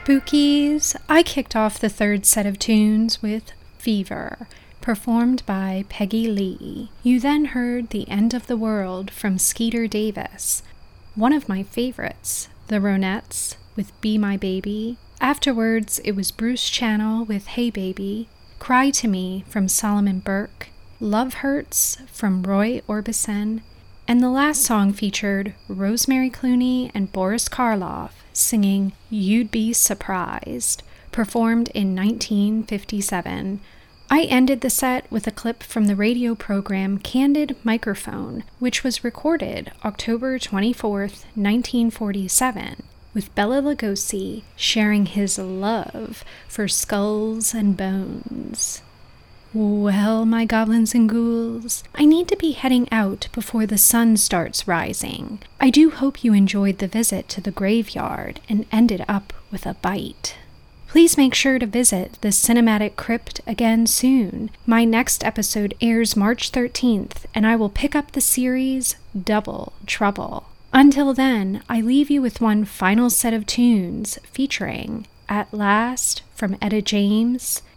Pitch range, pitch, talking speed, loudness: 205-245 Hz, 225 Hz, 135 wpm, -20 LUFS